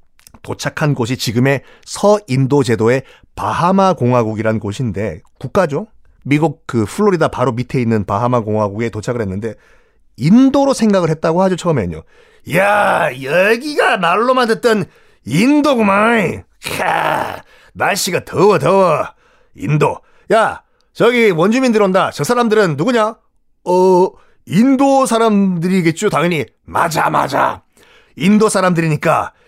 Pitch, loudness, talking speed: 175 Hz, -14 LUFS, 270 characters per minute